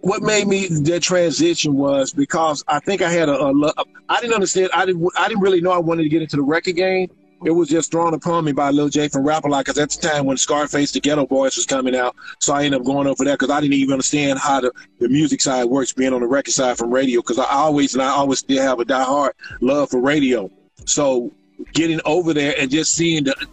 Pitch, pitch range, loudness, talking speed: 150 Hz, 135-170 Hz, -18 LUFS, 260 wpm